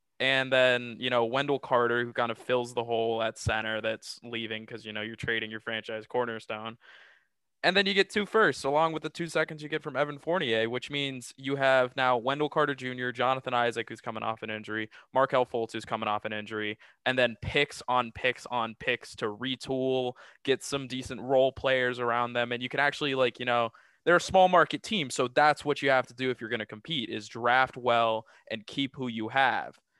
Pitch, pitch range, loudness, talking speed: 125 Hz, 115-140 Hz, -29 LUFS, 220 wpm